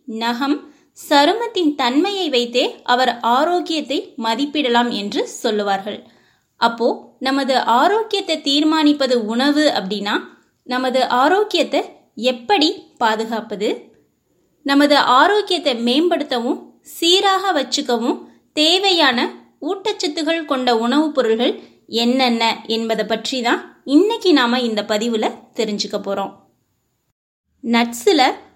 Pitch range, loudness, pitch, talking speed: 235-320 Hz, -17 LUFS, 270 Hz, 85 wpm